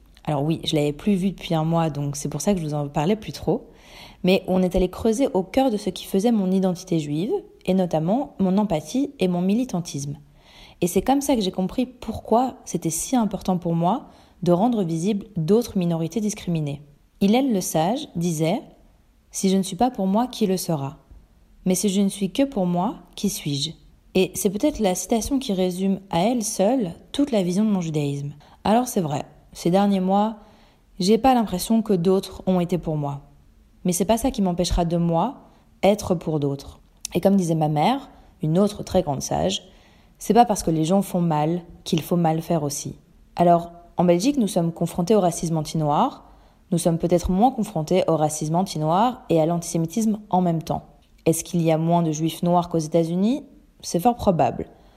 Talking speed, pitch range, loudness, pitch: 205 wpm, 165-210 Hz, -22 LUFS, 185 Hz